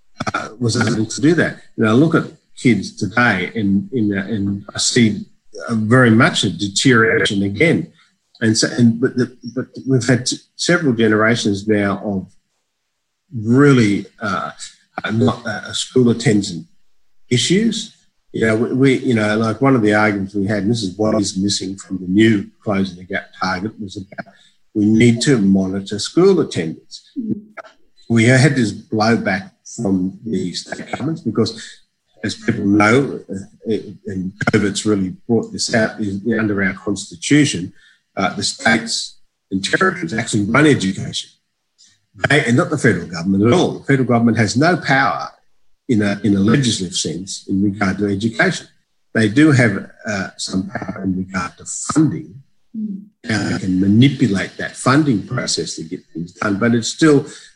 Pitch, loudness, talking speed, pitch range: 110 Hz, -17 LUFS, 165 wpm, 100-130 Hz